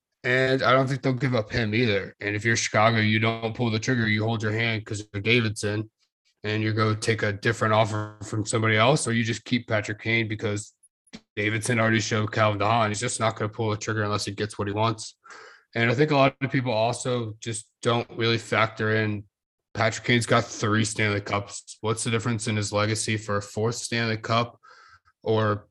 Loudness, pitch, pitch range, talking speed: -25 LUFS, 110 Hz, 105-115 Hz, 215 wpm